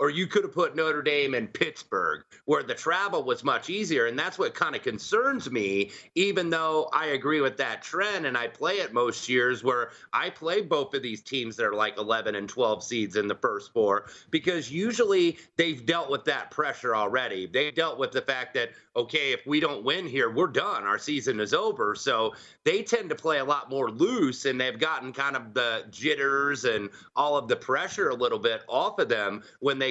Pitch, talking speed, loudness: 155 Hz, 215 wpm, -27 LUFS